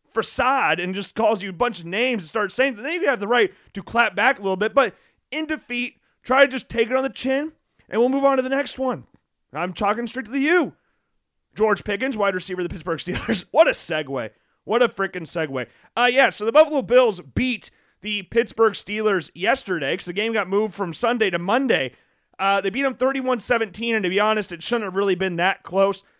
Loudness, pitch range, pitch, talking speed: -22 LUFS, 195-255 Hz, 220 Hz, 230 wpm